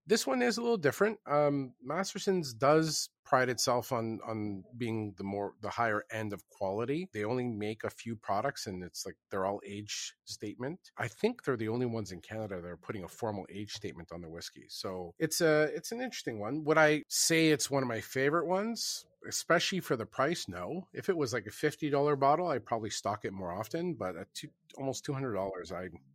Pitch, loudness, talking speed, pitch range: 125 Hz, -33 LUFS, 220 wpm, 105-155 Hz